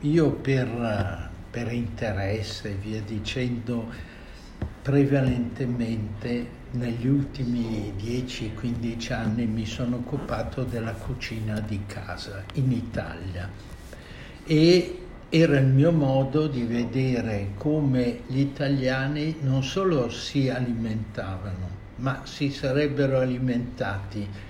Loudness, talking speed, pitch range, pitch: -26 LUFS, 95 wpm, 110-135 Hz, 120 Hz